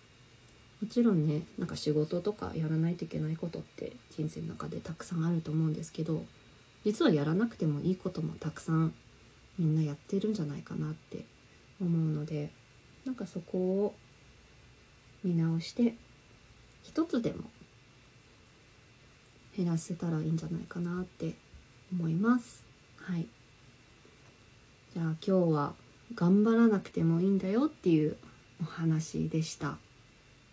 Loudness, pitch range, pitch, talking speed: -33 LUFS, 155-190 Hz, 165 Hz, 280 characters per minute